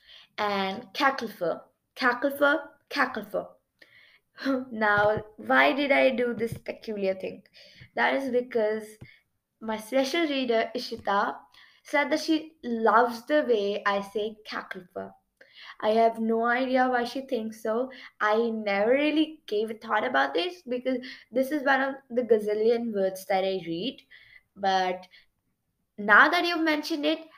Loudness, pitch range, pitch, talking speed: -26 LUFS, 210-270 Hz, 230 Hz, 135 wpm